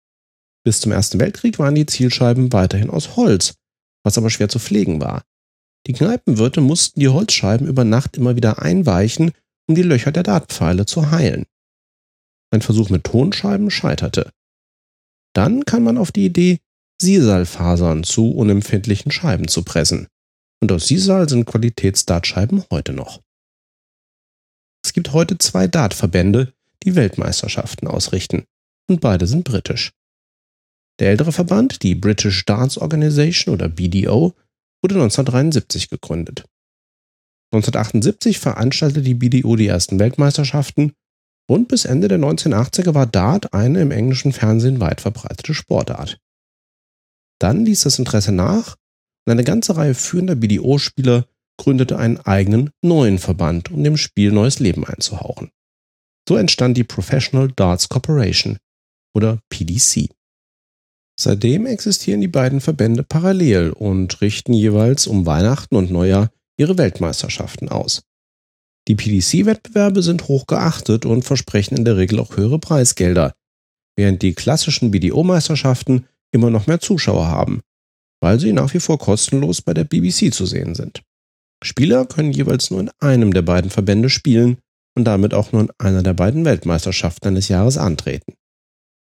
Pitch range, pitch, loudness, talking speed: 100-150 Hz, 120 Hz, -16 LUFS, 135 wpm